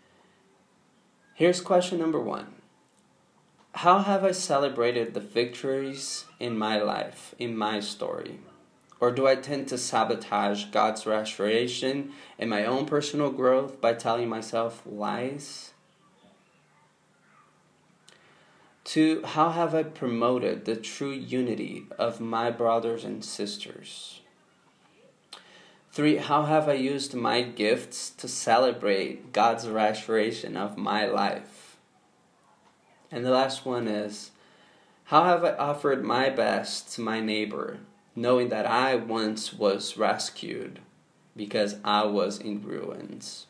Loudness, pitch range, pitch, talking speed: -27 LUFS, 110-140 Hz, 120 Hz, 115 wpm